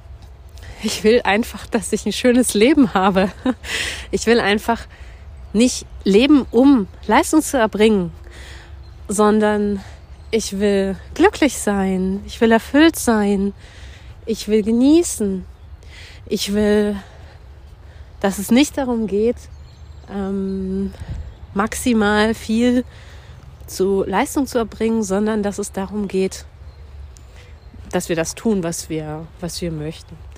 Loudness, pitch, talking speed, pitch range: -18 LUFS, 205 Hz, 115 wpm, 165-225 Hz